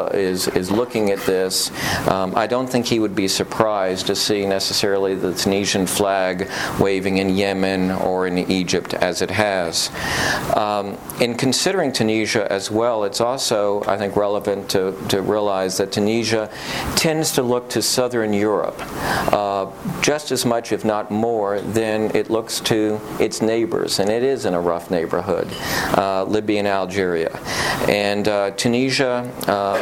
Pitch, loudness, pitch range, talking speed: 100 Hz, -20 LUFS, 95-115 Hz, 155 wpm